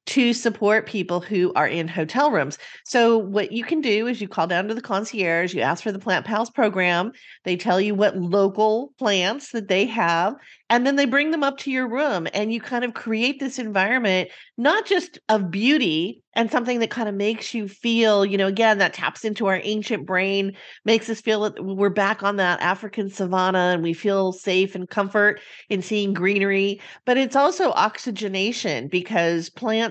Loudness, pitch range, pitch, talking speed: -22 LUFS, 190-235 Hz, 210 Hz, 195 wpm